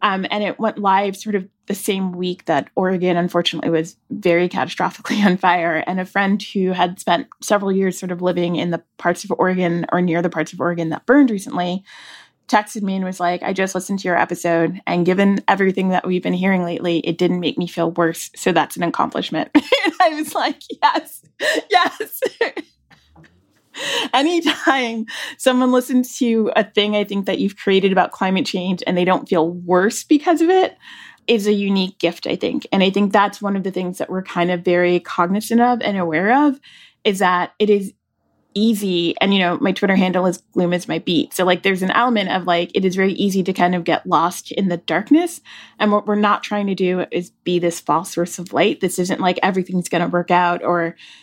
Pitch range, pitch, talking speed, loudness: 175-210 Hz, 185 Hz, 210 wpm, -18 LUFS